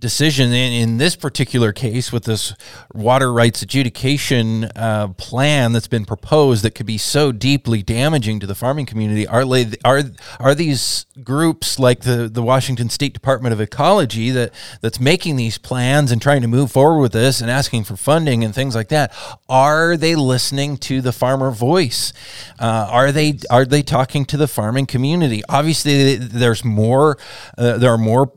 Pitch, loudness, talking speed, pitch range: 125 Hz, -16 LUFS, 180 wpm, 115-140 Hz